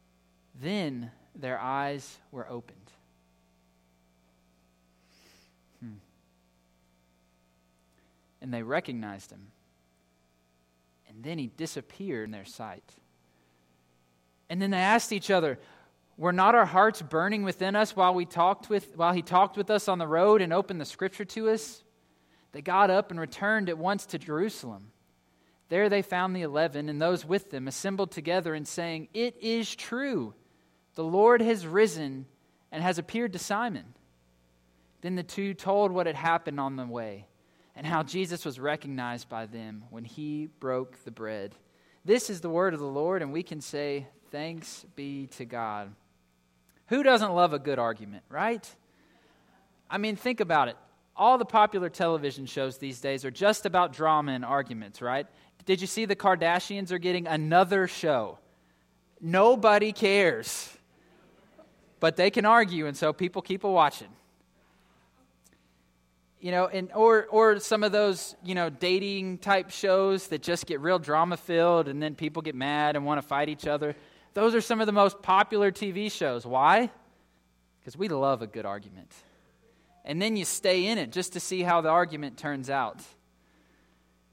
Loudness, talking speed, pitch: -27 LUFS, 160 wpm, 155 Hz